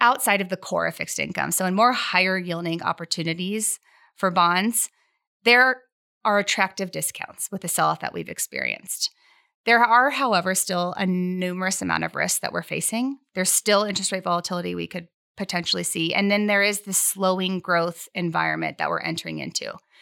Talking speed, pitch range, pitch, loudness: 175 wpm, 175-225 Hz, 190 Hz, -23 LUFS